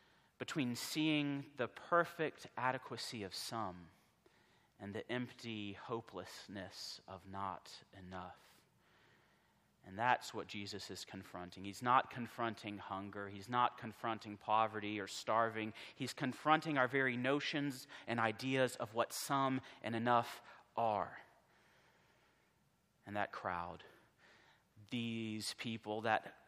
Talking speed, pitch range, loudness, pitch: 110 wpm, 100-130 Hz, -40 LUFS, 115 Hz